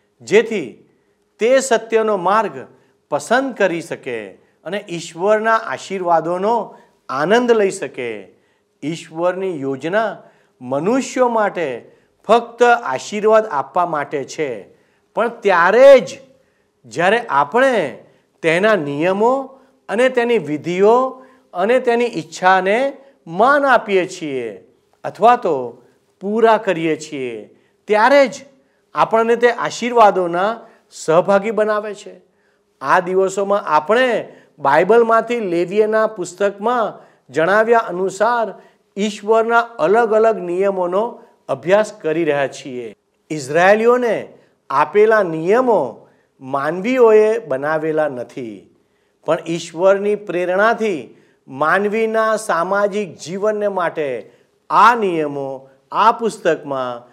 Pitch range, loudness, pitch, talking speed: 175-235 Hz, -16 LUFS, 210 Hz, 90 wpm